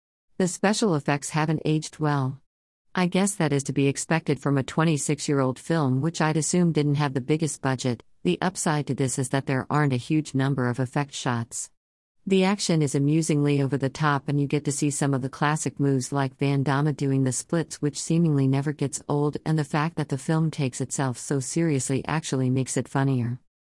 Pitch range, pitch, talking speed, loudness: 135-155 Hz, 145 Hz, 205 wpm, -25 LUFS